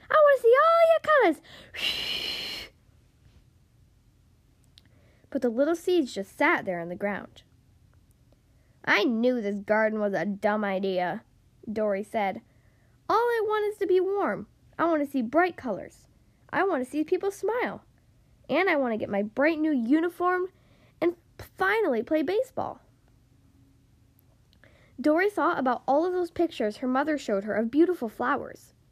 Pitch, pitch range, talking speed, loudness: 280 Hz, 205-340 Hz, 150 wpm, -26 LUFS